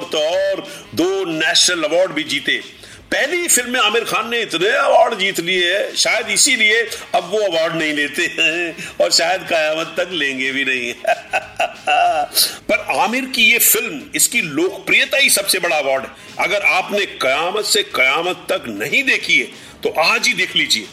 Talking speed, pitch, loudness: 150 wpm, 275 Hz, -15 LUFS